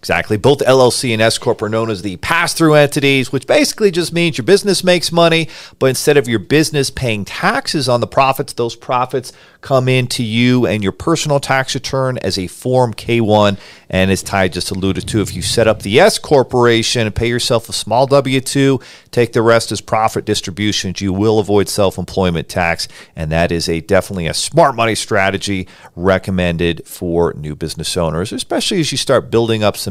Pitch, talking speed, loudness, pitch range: 115 Hz, 195 wpm, -14 LUFS, 95-135 Hz